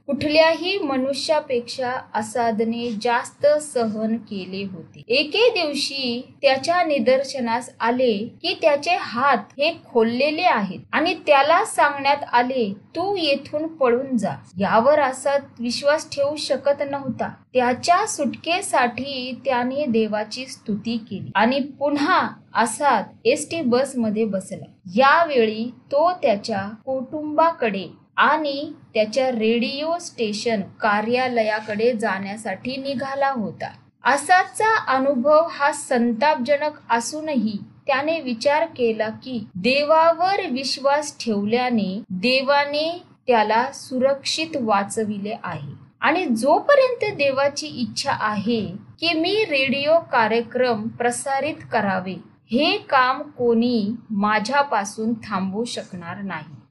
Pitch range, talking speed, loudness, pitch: 225-290 Hz, 95 wpm, -21 LUFS, 255 Hz